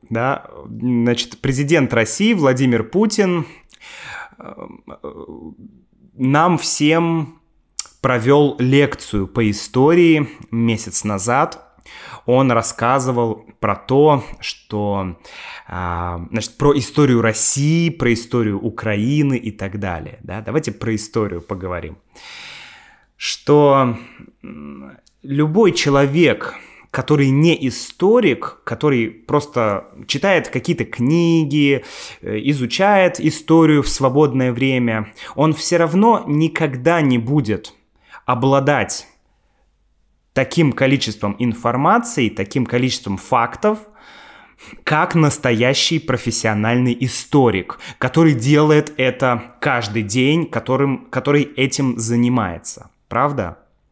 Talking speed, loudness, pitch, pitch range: 85 wpm, -17 LUFS, 130 Hz, 115-150 Hz